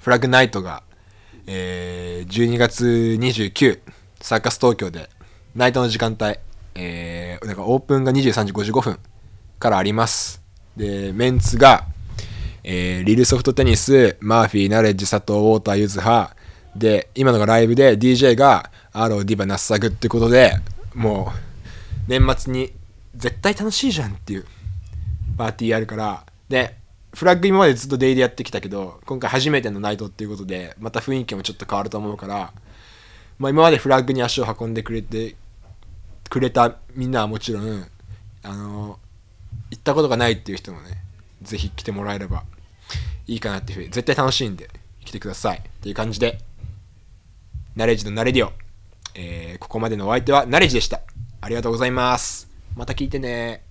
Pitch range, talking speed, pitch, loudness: 95-120 Hz, 345 characters per minute, 105 Hz, -19 LUFS